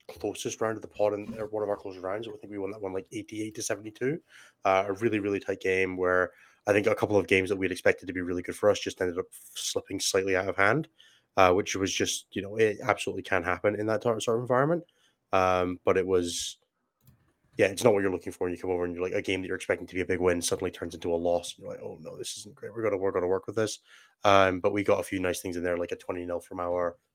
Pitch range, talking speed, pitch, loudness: 90-110 Hz, 285 wpm, 95 Hz, -29 LUFS